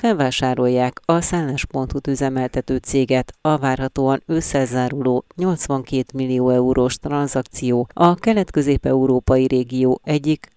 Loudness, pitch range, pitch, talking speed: -19 LUFS, 130-145 Hz, 130 Hz, 90 wpm